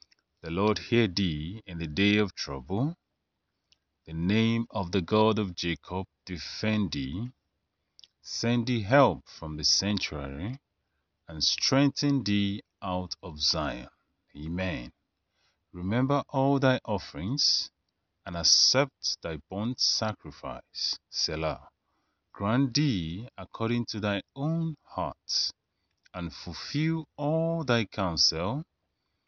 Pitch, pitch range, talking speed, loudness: 100 Hz, 85-120 Hz, 110 wpm, -28 LUFS